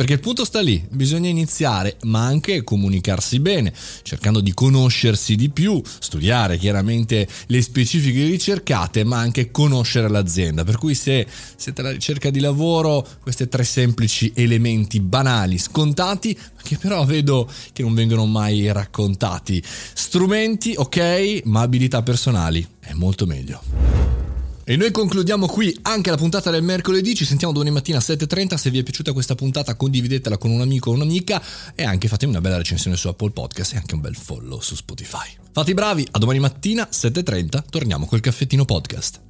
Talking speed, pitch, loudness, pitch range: 170 wpm, 125 Hz, -19 LUFS, 105-155 Hz